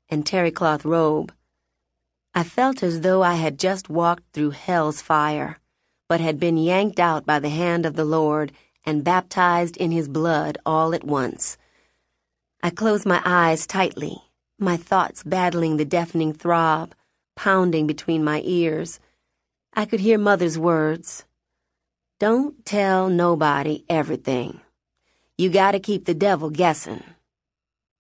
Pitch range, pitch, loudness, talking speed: 150-180 Hz, 165 Hz, -21 LUFS, 140 wpm